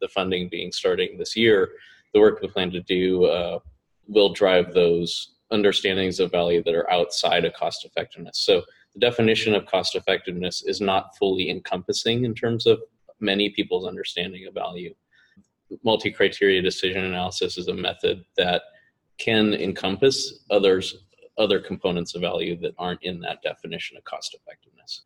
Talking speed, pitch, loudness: 160 wpm, 105 Hz, -23 LUFS